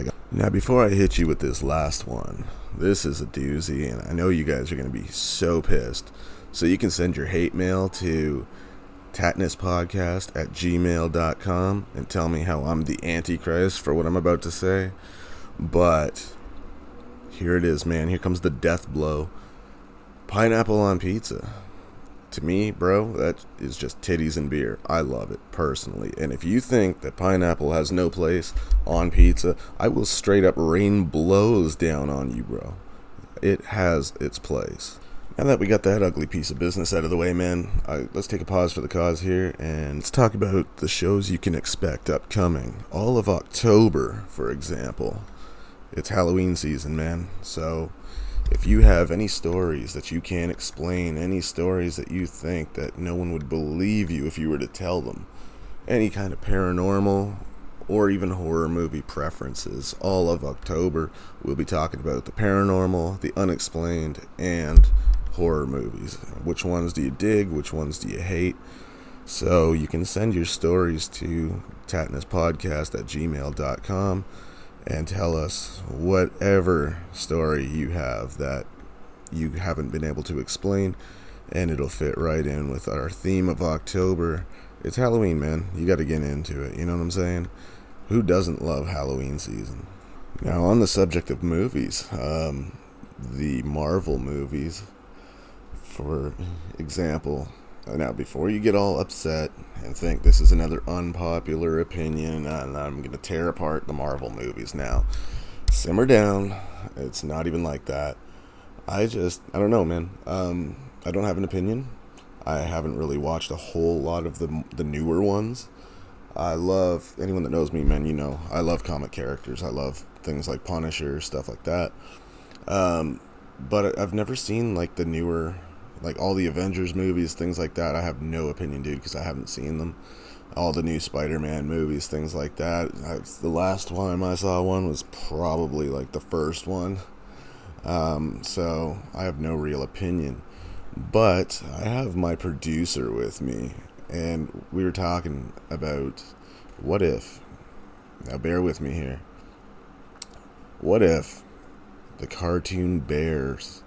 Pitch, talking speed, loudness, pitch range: 85 Hz, 165 wpm, -25 LUFS, 75-95 Hz